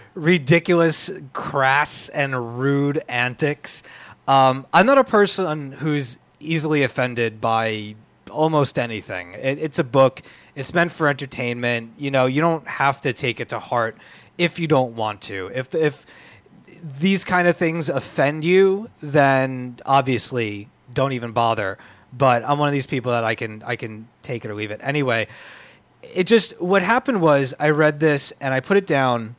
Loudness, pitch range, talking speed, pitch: -20 LUFS, 120-160 Hz, 165 wpm, 140 Hz